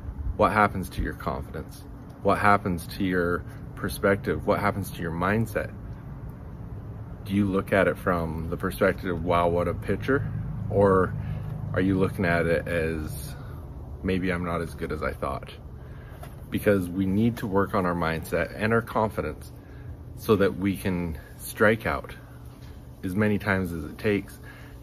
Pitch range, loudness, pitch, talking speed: 90-105 Hz, -26 LUFS, 100 Hz, 160 wpm